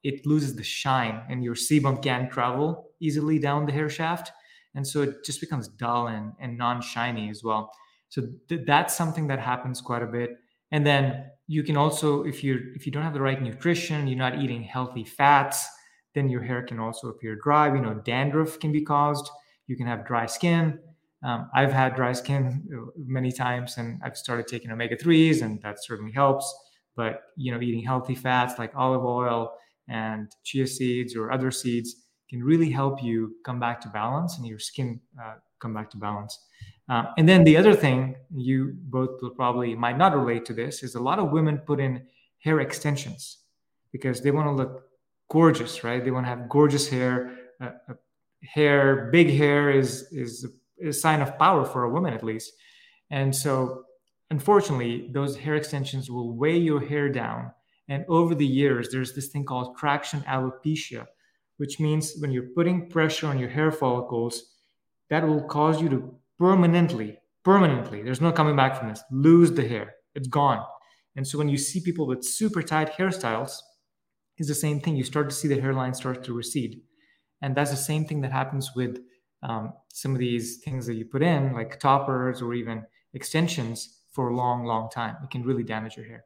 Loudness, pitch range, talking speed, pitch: -25 LUFS, 120-150 Hz, 195 wpm, 135 Hz